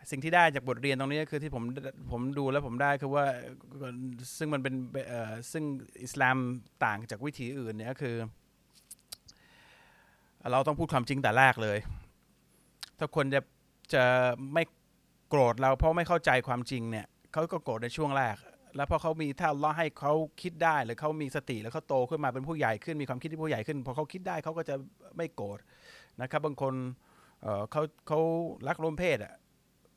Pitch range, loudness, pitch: 125-155 Hz, -31 LUFS, 140 Hz